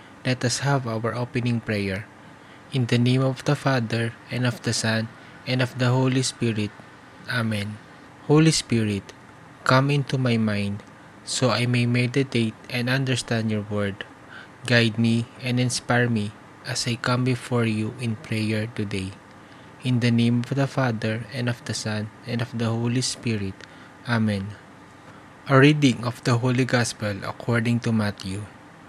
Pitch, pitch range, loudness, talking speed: 120 Hz, 110-130 Hz, -24 LUFS, 155 wpm